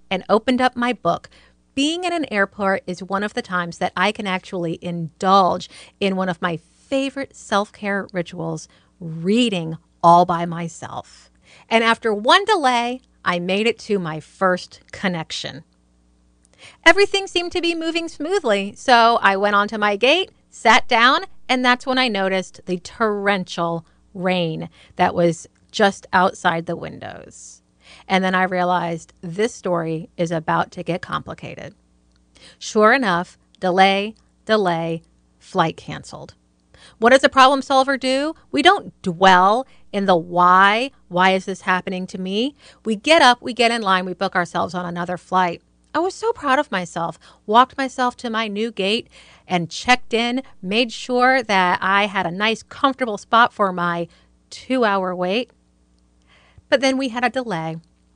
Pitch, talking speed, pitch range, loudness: 195 Hz, 155 wpm, 175-240 Hz, -19 LUFS